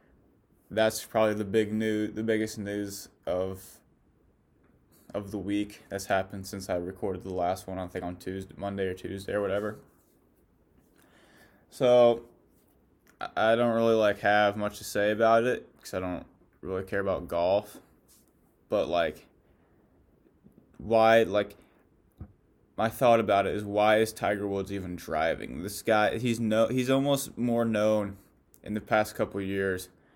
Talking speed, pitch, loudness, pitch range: 150 wpm, 105 Hz, -28 LUFS, 95-110 Hz